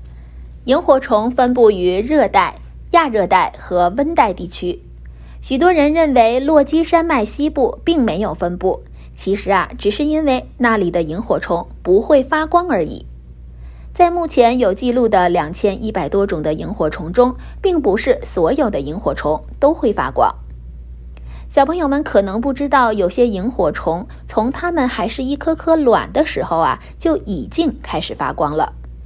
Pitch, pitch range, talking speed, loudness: 230 Hz, 175-295 Hz, 240 characters per minute, -16 LUFS